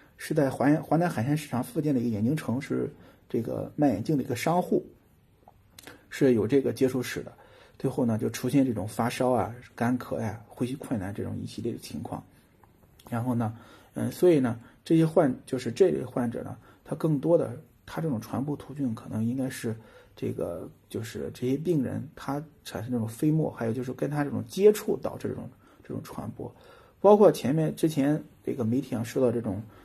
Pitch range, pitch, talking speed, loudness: 115-150 Hz, 125 Hz, 290 characters per minute, -28 LUFS